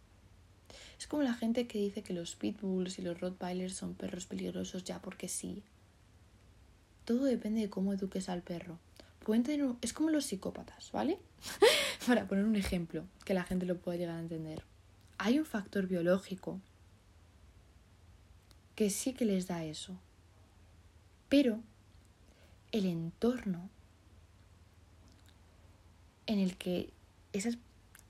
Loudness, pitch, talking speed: -35 LUFS, 170 Hz, 130 wpm